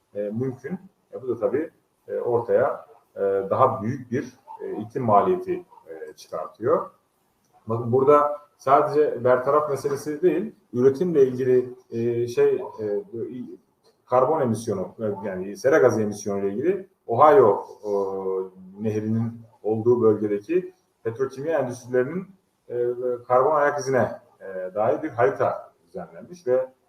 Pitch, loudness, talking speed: 135 Hz, -23 LUFS, 120 wpm